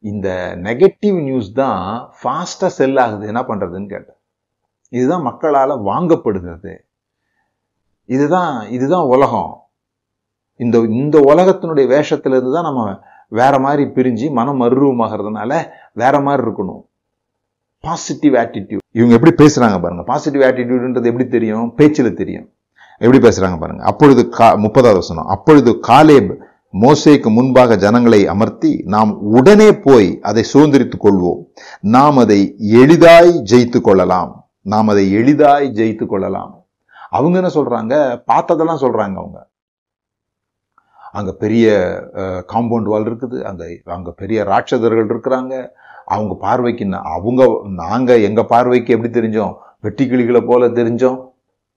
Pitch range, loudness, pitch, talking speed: 105-135 Hz, -12 LUFS, 120 Hz, 115 wpm